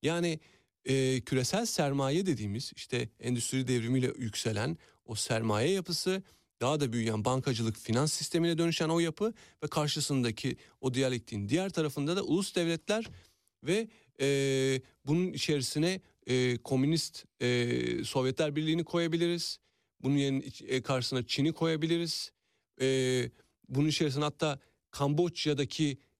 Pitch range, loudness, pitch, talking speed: 125-165 Hz, -32 LUFS, 140 Hz, 115 wpm